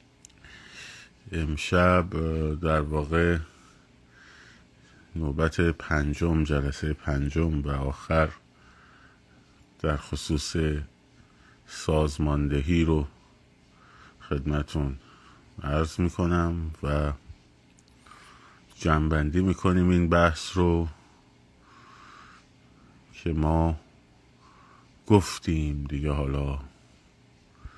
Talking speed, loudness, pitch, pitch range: 60 wpm, -27 LUFS, 75 Hz, 70-85 Hz